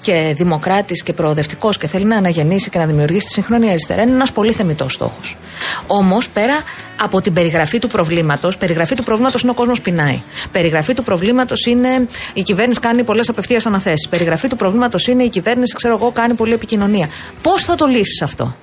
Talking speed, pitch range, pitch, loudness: 190 wpm, 175-240 Hz, 205 Hz, -15 LUFS